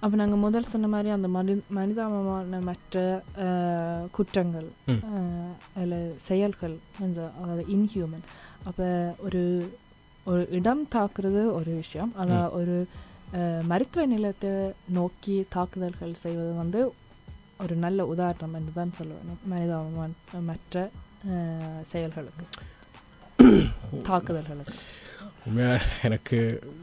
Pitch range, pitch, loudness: 165-195 Hz, 180 Hz, -28 LUFS